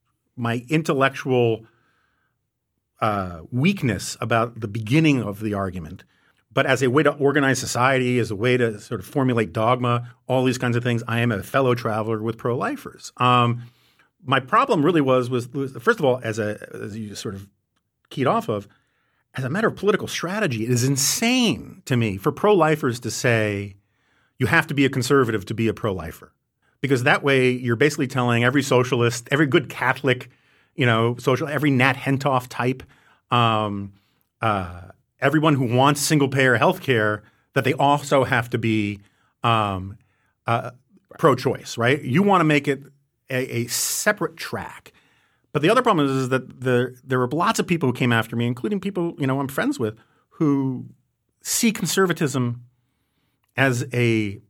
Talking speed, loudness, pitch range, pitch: 175 wpm, -21 LUFS, 115-140 Hz, 125 Hz